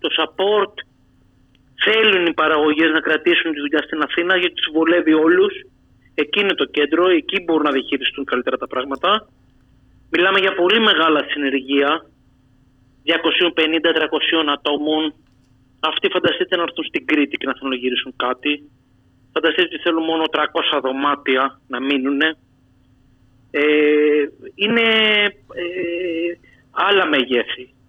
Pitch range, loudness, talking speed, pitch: 135-170 Hz, -17 LUFS, 125 wpm, 155 Hz